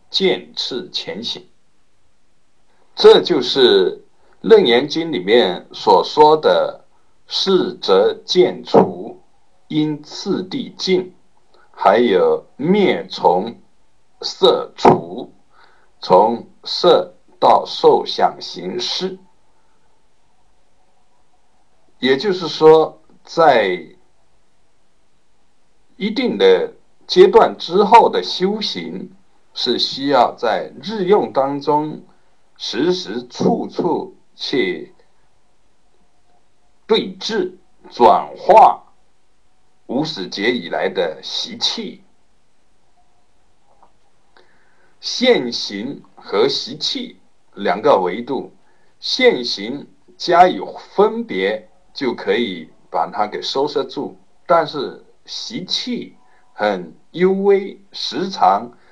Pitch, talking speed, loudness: 390 Hz, 110 characters per minute, -16 LUFS